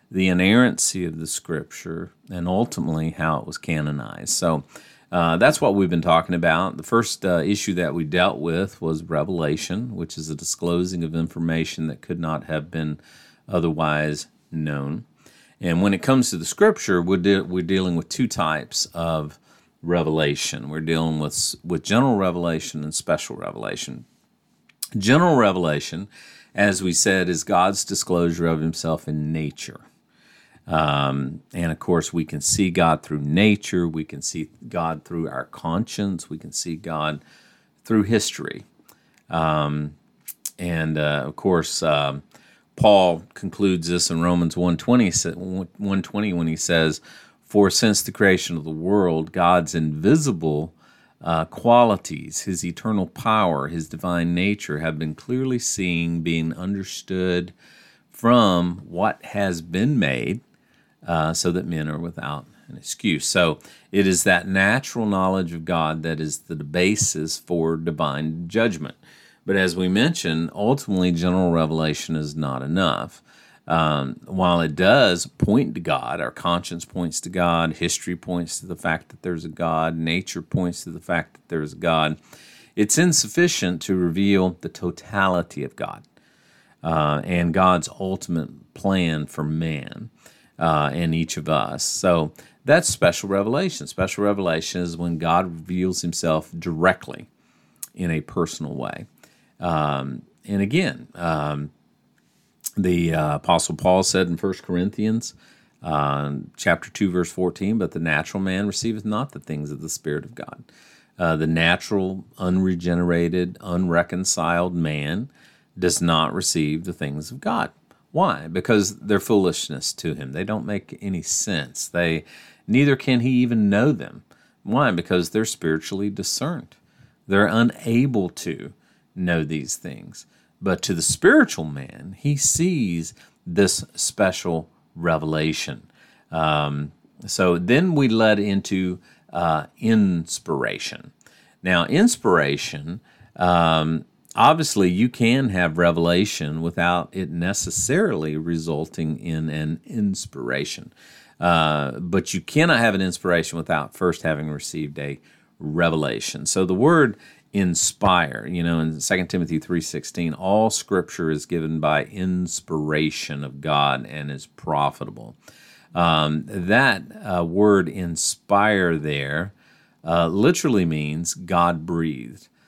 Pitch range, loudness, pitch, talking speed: 80-95 Hz, -22 LUFS, 85 Hz, 135 wpm